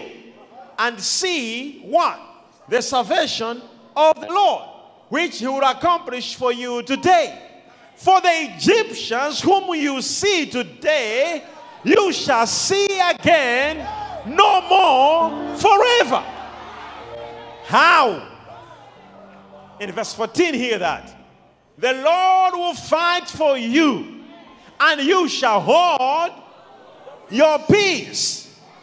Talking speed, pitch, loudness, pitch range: 100 wpm, 315 Hz, -18 LUFS, 265-350 Hz